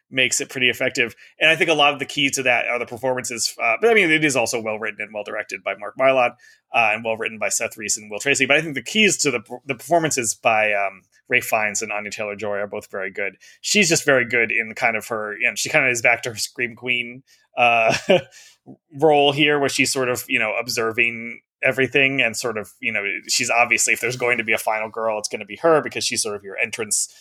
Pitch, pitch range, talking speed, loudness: 120 Hz, 110-140 Hz, 260 wpm, -19 LUFS